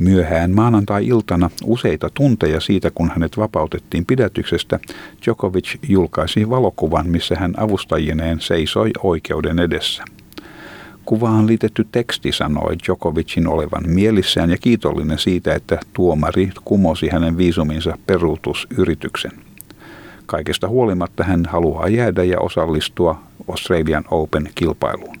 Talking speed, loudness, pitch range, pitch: 100 wpm, -18 LUFS, 80-110 Hz, 90 Hz